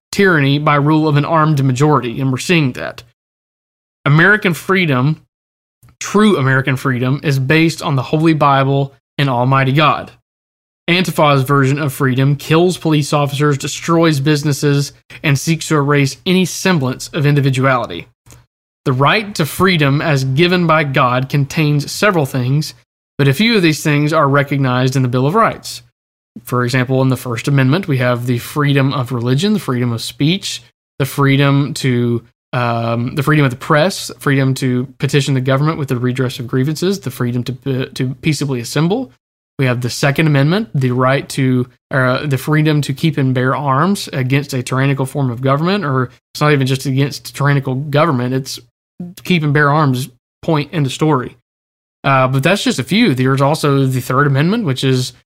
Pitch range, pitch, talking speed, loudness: 130-155 Hz, 140 Hz, 175 wpm, -14 LUFS